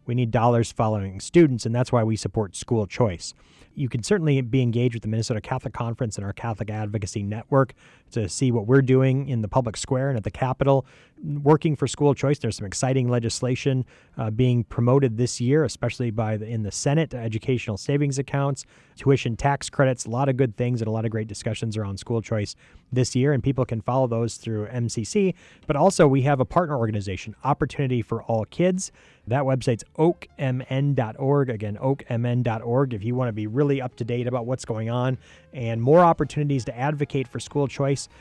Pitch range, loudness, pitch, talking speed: 115-140 Hz, -24 LUFS, 125 Hz, 195 wpm